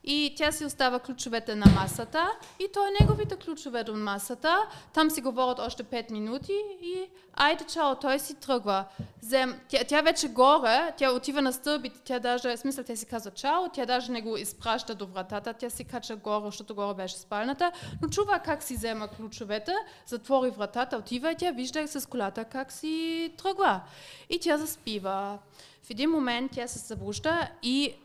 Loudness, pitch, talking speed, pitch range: -29 LUFS, 255 Hz, 180 wpm, 230-310 Hz